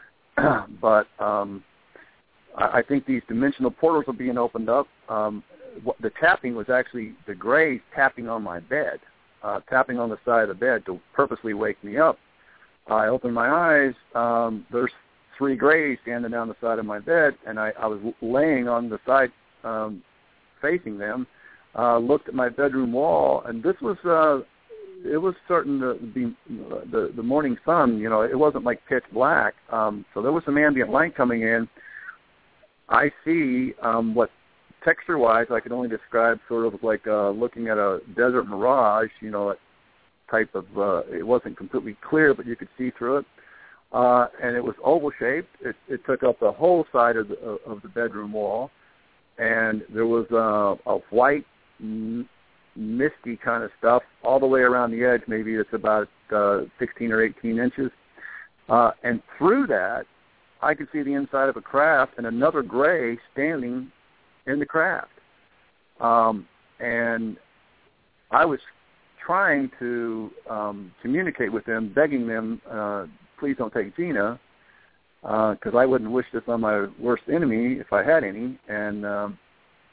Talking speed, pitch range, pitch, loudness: 170 wpm, 110-135 Hz, 120 Hz, -23 LUFS